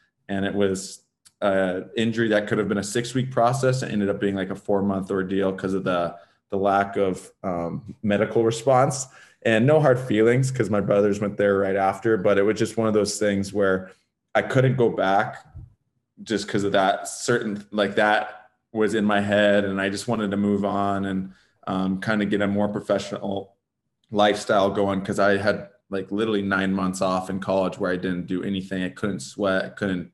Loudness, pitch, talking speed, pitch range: -23 LUFS, 100 Hz, 200 wpm, 95-110 Hz